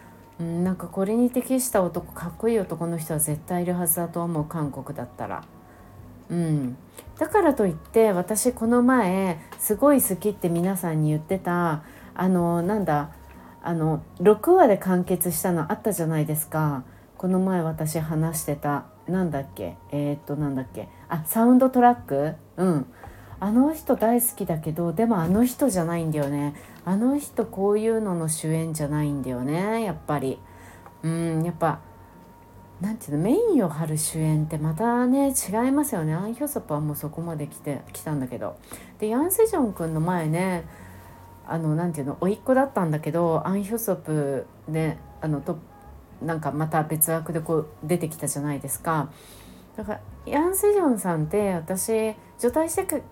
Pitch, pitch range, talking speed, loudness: 170 Hz, 150-210 Hz, 335 characters per minute, -24 LUFS